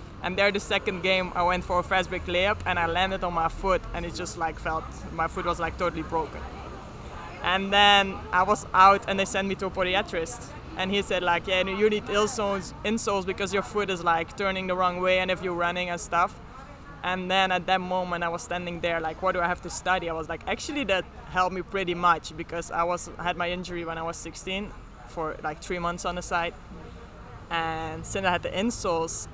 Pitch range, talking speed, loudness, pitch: 170-190 Hz, 230 wpm, -26 LUFS, 180 Hz